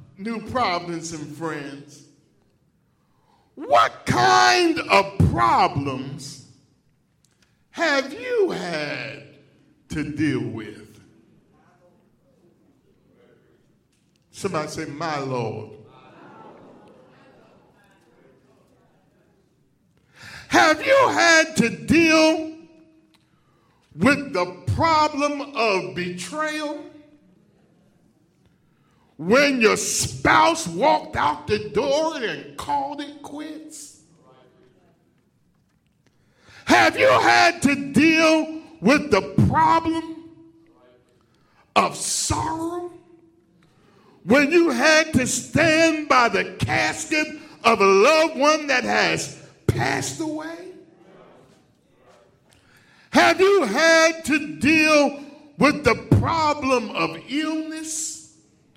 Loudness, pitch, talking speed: -20 LUFS, 285 Hz, 75 wpm